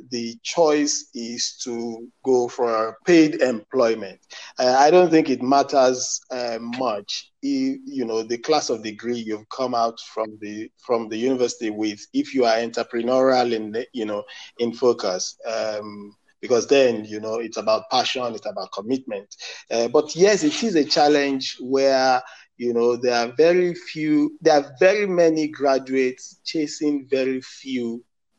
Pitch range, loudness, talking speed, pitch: 115-145 Hz, -21 LUFS, 155 wpm, 125 Hz